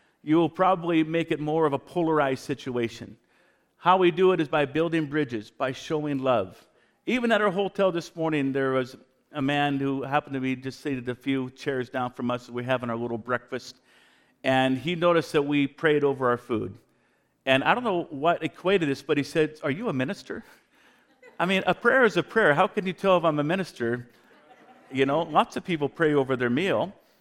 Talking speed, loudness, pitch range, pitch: 210 wpm, -25 LUFS, 130-165 Hz, 145 Hz